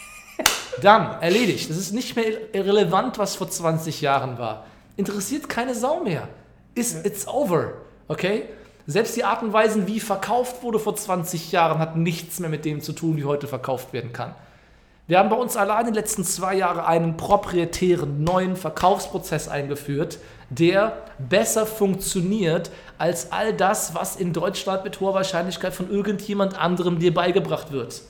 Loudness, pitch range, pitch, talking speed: -23 LUFS, 165-205 Hz, 185 Hz, 160 wpm